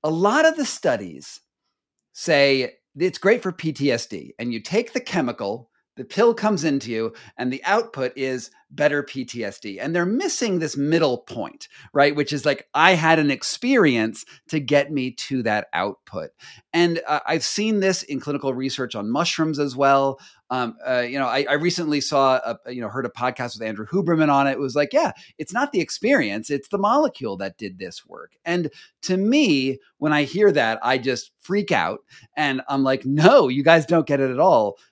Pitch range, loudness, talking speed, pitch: 130-170 Hz, -21 LUFS, 195 wpm, 145 Hz